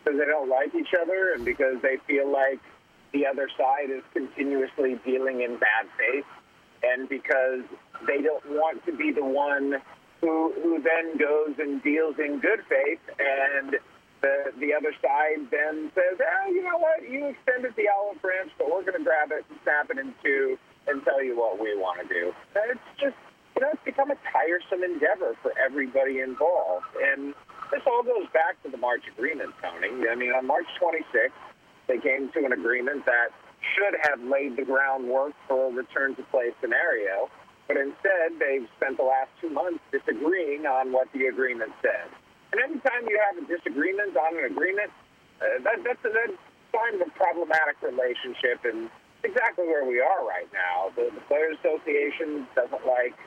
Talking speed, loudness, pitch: 185 wpm, -26 LUFS, 155 Hz